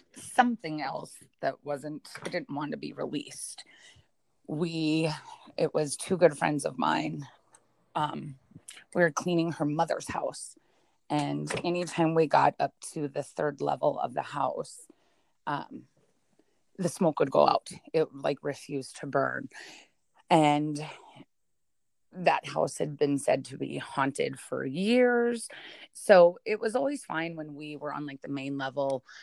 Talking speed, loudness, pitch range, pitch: 145 wpm, -29 LUFS, 145-180 Hz, 160 Hz